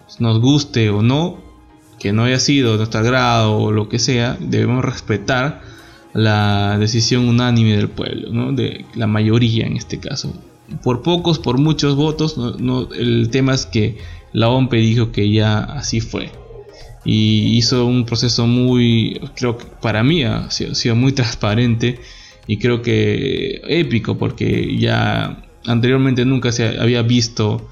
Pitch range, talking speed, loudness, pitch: 110-125 Hz, 160 wpm, -16 LUFS, 120 Hz